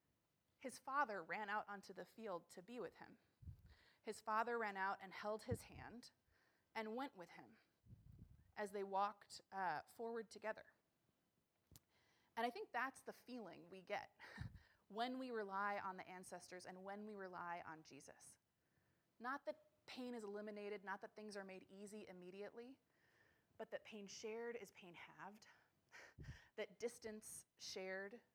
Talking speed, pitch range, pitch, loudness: 150 wpm, 195-230 Hz, 210 Hz, -50 LUFS